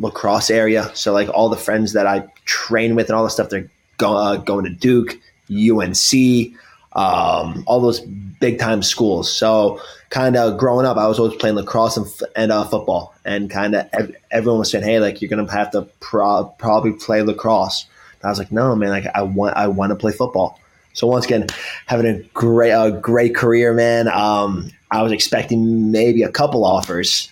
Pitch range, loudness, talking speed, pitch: 105-115 Hz, -17 LUFS, 200 wpm, 110 Hz